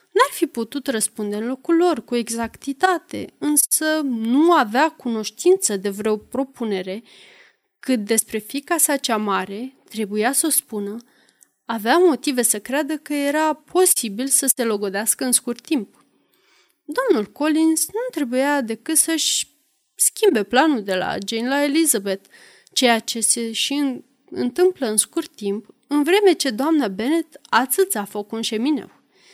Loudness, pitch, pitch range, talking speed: -20 LUFS, 260 Hz, 225-310 Hz, 145 wpm